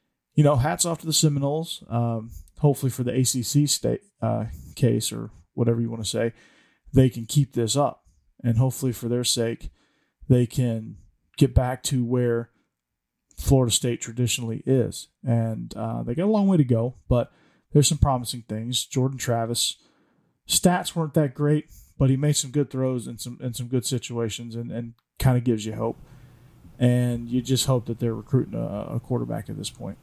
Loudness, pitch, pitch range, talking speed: -24 LUFS, 125 Hz, 115-135 Hz, 185 wpm